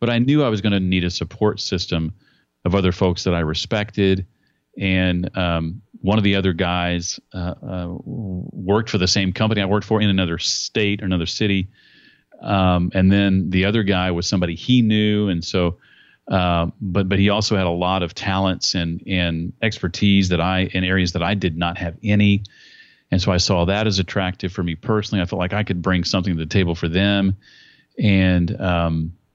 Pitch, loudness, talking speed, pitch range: 95 Hz, -20 LUFS, 200 wpm, 90-100 Hz